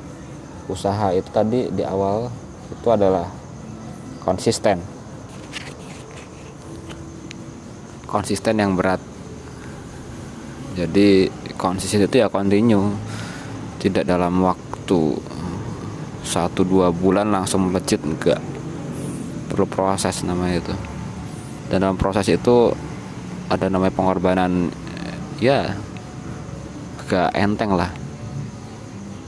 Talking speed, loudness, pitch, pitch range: 80 wpm, -21 LUFS, 95 Hz, 90-105 Hz